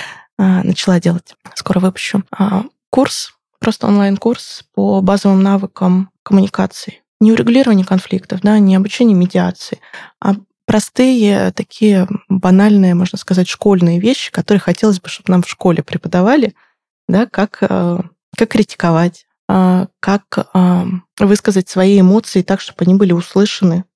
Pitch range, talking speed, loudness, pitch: 185-210 Hz, 120 wpm, -13 LUFS, 195 Hz